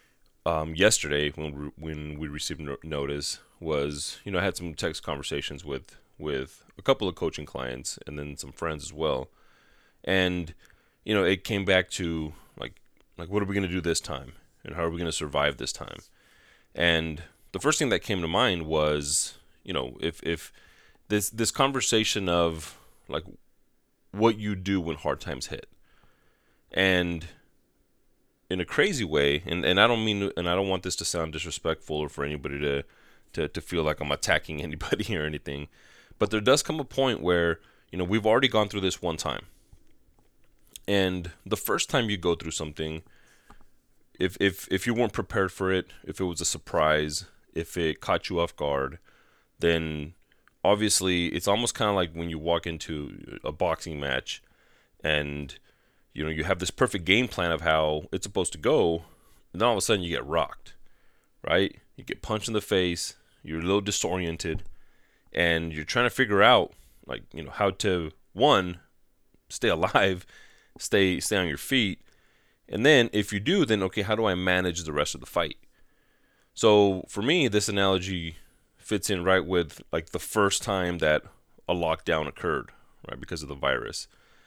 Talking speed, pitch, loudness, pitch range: 185 wpm, 85 Hz, -27 LUFS, 75-100 Hz